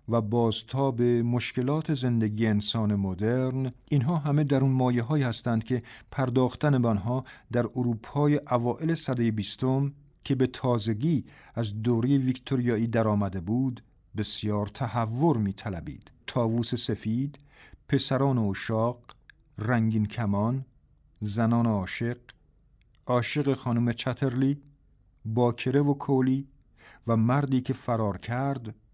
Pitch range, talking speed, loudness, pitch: 110-135 Hz, 110 wpm, -27 LUFS, 120 Hz